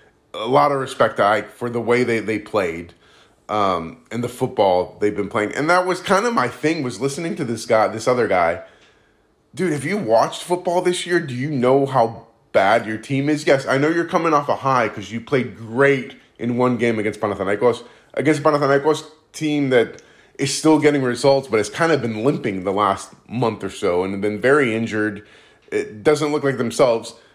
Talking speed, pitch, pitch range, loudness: 210 wpm, 125 Hz, 115-150 Hz, -19 LUFS